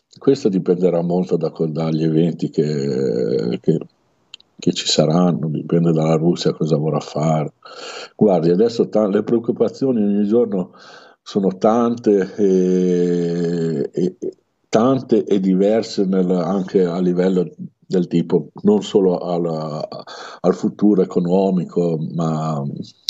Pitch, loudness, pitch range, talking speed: 90 Hz, -18 LUFS, 85-105 Hz, 100 wpm